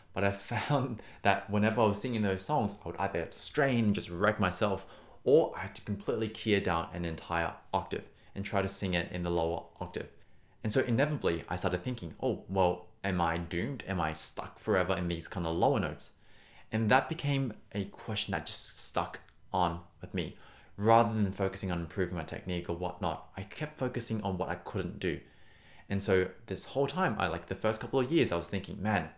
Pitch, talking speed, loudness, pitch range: 100 Hz, 210 wpm, -32 LUFS, 90-110 Hz